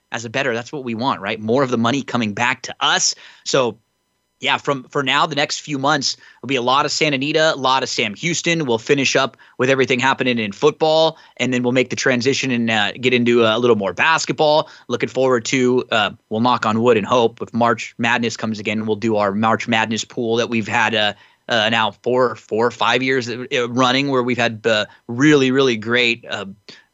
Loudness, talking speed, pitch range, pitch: -18 LUFS, 225 wpm, 115-140 Hz, 125 Hz